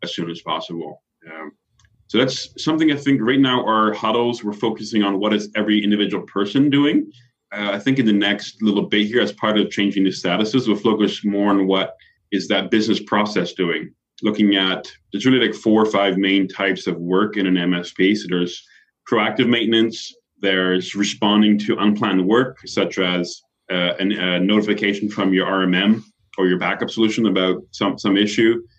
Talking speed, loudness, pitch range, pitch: 185 wpm, -19 LUFS, 95-110 Hz, 105 Hz